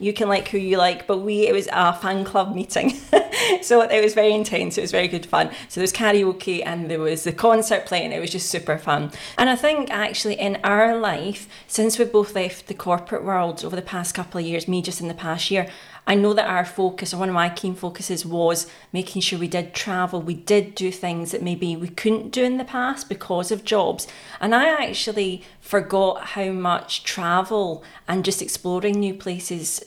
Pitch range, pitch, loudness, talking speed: 180-210 Hz, 190 Hz, -22 LUFS, 220 wpm